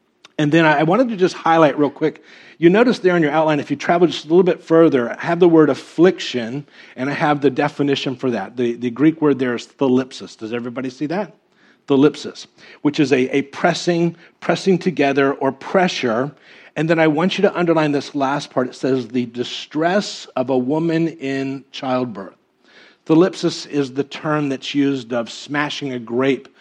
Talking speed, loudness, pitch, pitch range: 190 wpm, -18 LUFS, 145 Hz, 130-165 Hz